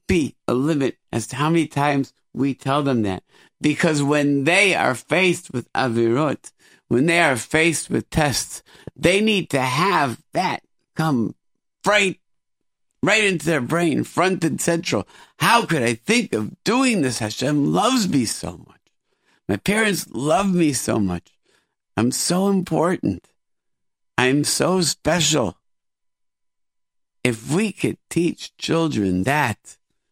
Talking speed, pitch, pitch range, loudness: 135 wpm, 155 Hz, 130-175 Hz, -20 LUFS